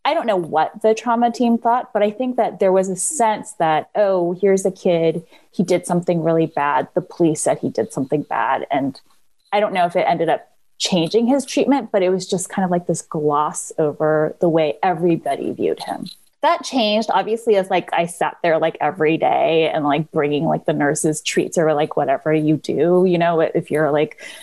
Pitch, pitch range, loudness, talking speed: 175 Hz, 160-215 Hz, -19 LUFS, 215 wpm